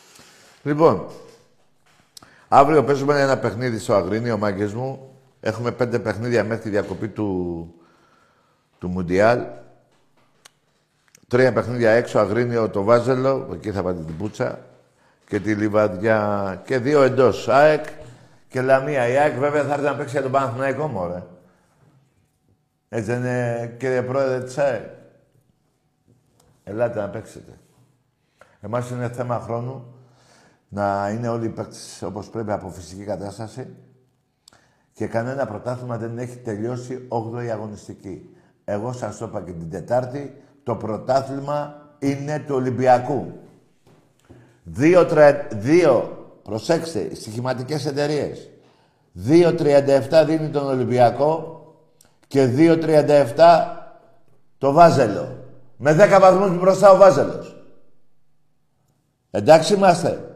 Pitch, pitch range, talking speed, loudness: 125 Hz, 110-145 Hz, 115 wpm, -19 LUFS